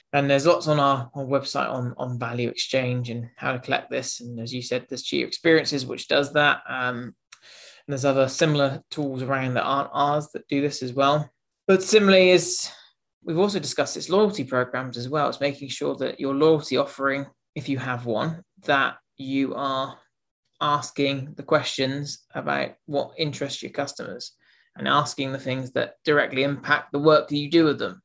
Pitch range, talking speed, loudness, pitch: 130-150 Hz, 190 wpm, -24 LUFS, 140 Hz